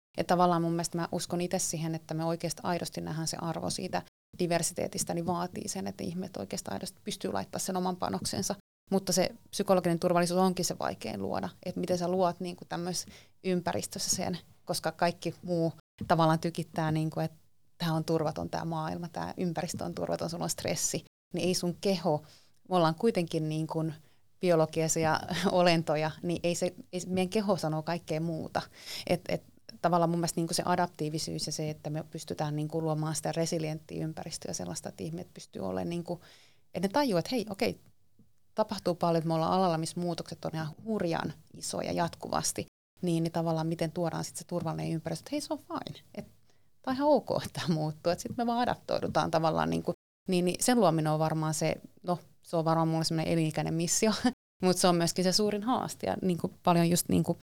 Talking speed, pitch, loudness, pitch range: 190 wpm, 170 Hz, -31 LUFS, 160-180 Hz